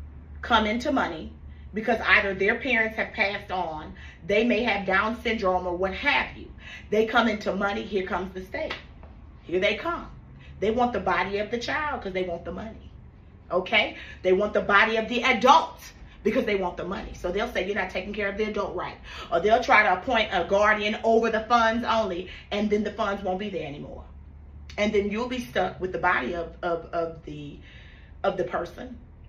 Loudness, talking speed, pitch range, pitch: -25 LUFS, 205 wpm, 180-225 Hz, 200 Hz